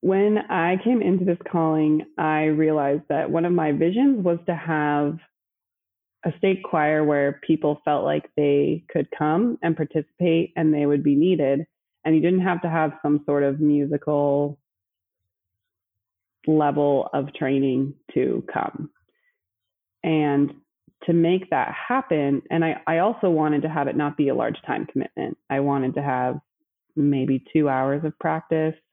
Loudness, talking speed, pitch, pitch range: -22 LUFS, 160 wpm, 150 Hz, 140-165 Hz